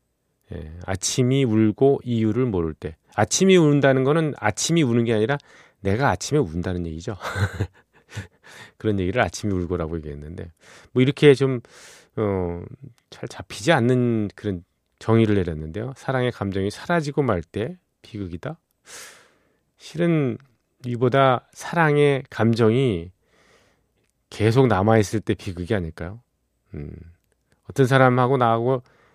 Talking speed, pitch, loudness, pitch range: 270 characters per minute, 115 Hz, -21 LUFS, 95-135 Hz